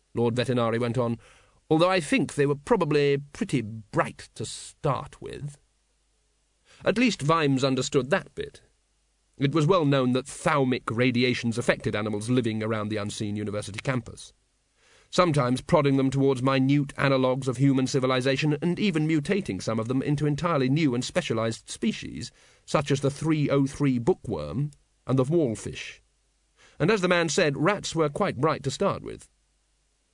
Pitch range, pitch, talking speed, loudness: 125-150 Hz, 135 Hz, 155 wpm, -25 LUFS